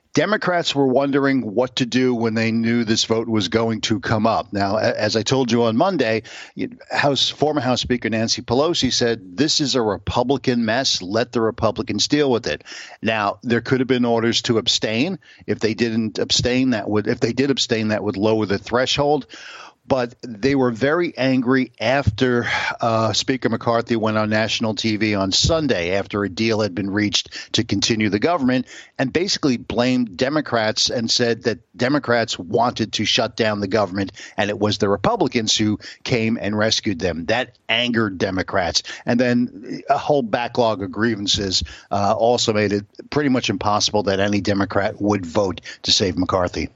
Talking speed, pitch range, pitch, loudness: 175 wpm, 105-125 Hz, 115 Hz, -20 LUFS